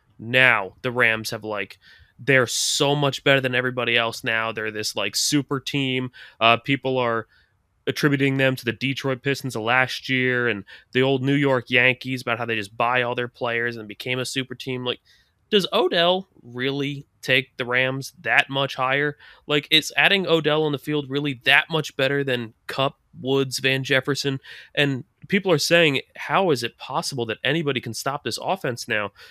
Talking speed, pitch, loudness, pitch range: 185 wpm, 130 Hz, -22 LUFS, 120-140 Hz